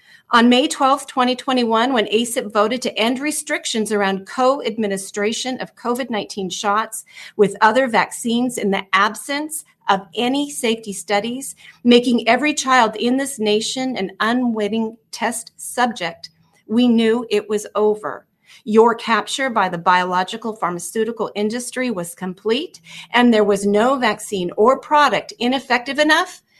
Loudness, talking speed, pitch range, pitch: -18 LUFS, 130 wpm, 210-255 Hz, 230 Hz